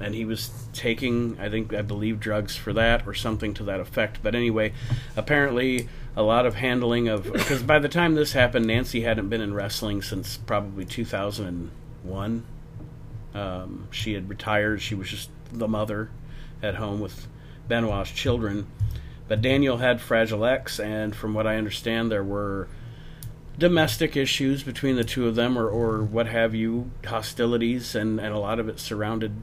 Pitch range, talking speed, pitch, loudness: 105-125 Hz, 170 wpm, 115 Hz, -25 LUFS